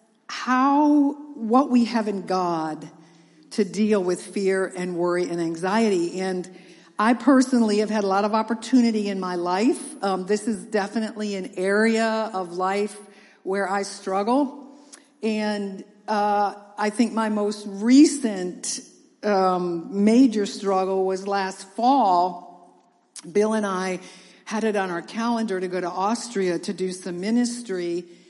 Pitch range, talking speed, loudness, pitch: 185-225 Hz, 140 wpm, -23 LUFS, 205 Hz